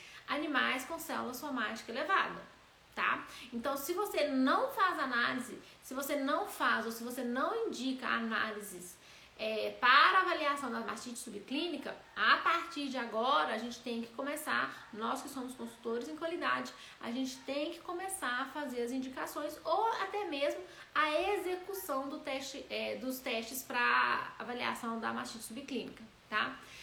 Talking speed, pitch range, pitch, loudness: 150 wpm, 240-305 Hz, 270 Hz, -35 LUFS